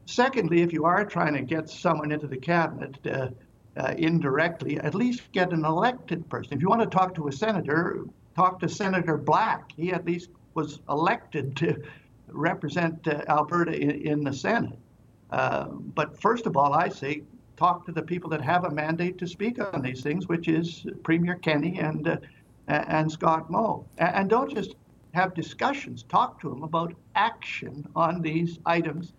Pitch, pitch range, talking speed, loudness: 165 Hz, 150-175 Hz, 180 wpm, -27 LUFS